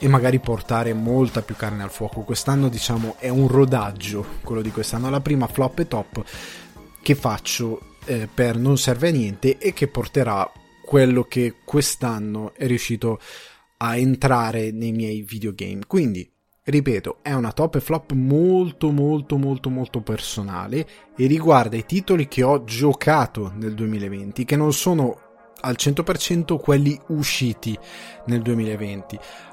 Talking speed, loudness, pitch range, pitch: 145 wpm, -21 LUFS, 110-140 Hz, 125 Hz